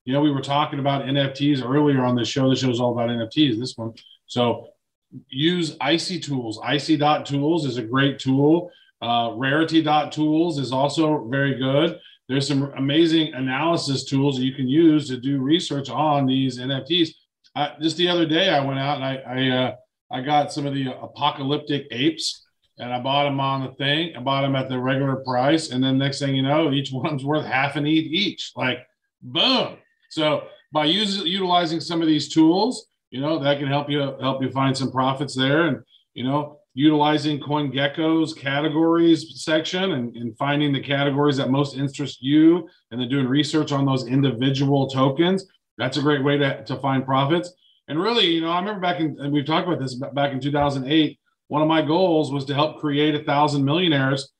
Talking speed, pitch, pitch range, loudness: 195 wpm, 145 Hz, 135-155 Hz, -21 LUFS